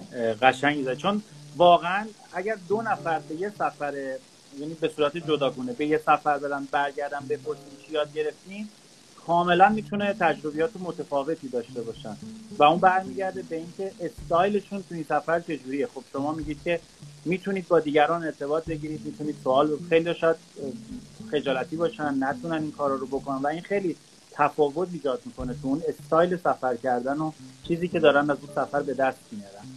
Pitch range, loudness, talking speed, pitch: 140-170 Hz, -26 LUFS, 165 wpm, 150 Hz